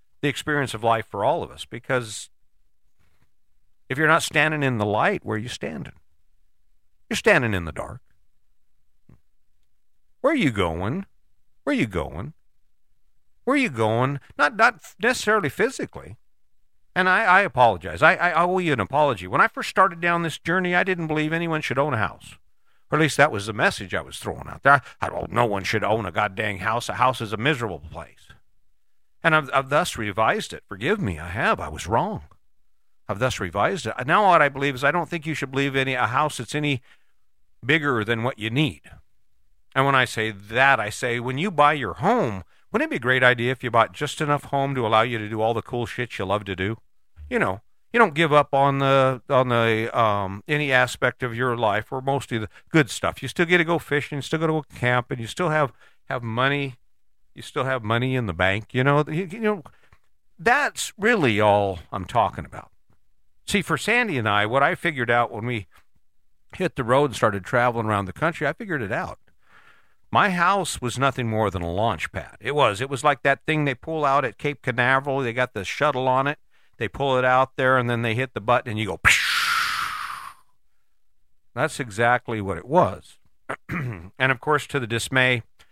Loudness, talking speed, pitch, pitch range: -22 LUFS, 210 wpm, 125 Hz, 110-145 Hz